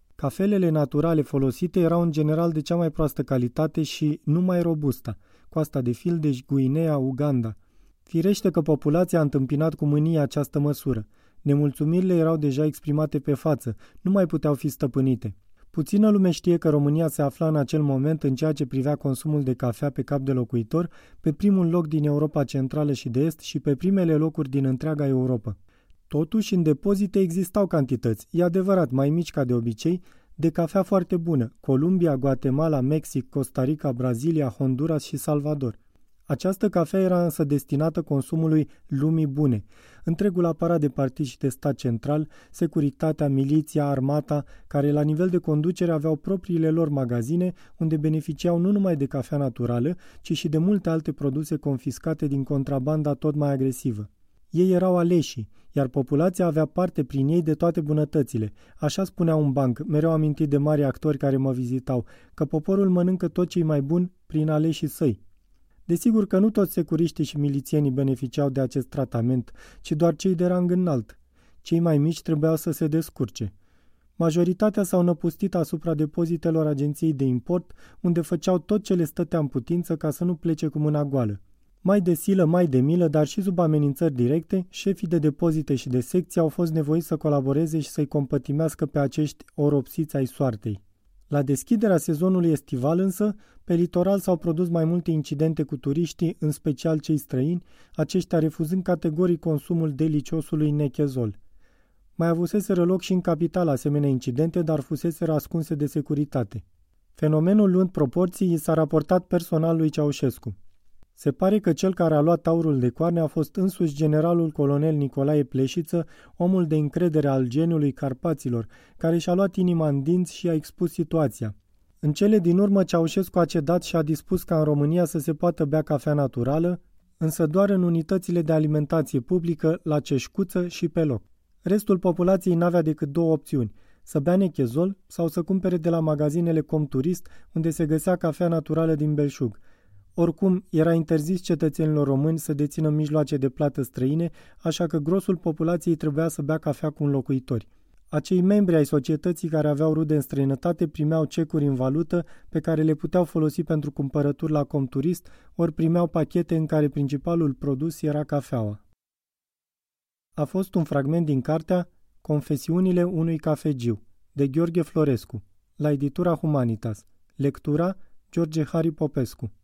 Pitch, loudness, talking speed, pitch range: 155 Hz, -24 LUFS, 165 wpm, 140-170 Hz